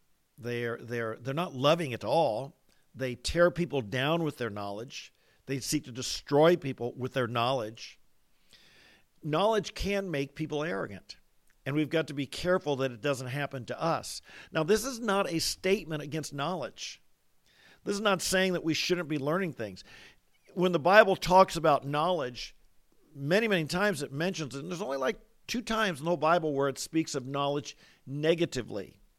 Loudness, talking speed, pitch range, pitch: -30 LUFS, 175 wpm, 135-180 Hz, 155 Hz